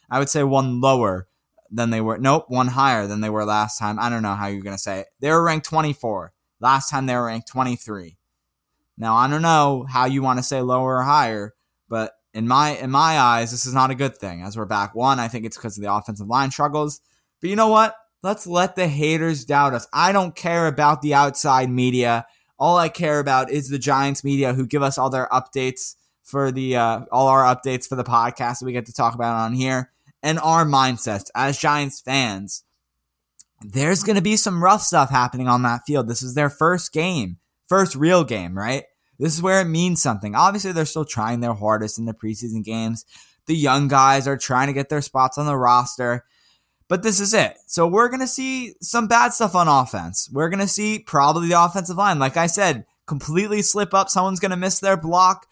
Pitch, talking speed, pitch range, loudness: 135 Hz, 220 wpm, 120-165 Hz, -20 LUFS